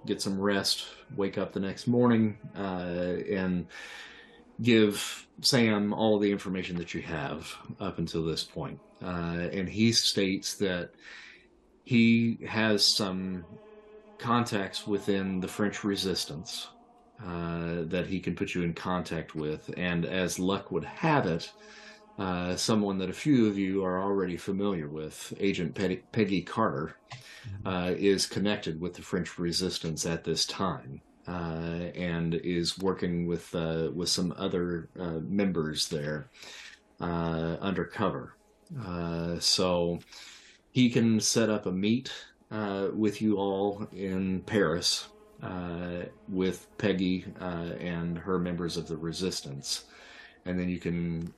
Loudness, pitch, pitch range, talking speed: -30 LUFS, 95 Hz, 85-100 Hz, 135 wpm